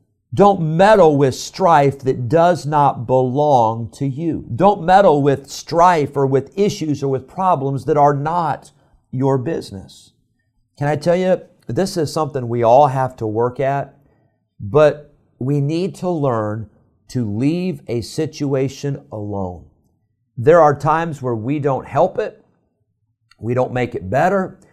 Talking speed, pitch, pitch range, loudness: 150 wpm, 140 Hz, 120-155 Hz, -17 LUFS